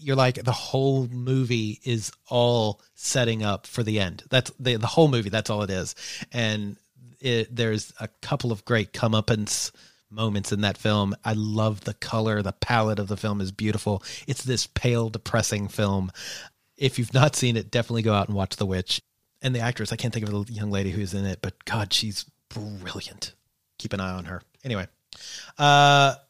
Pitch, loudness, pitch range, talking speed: 110 Hz, -25 LUFS, 100-120 Hz, 195 wpm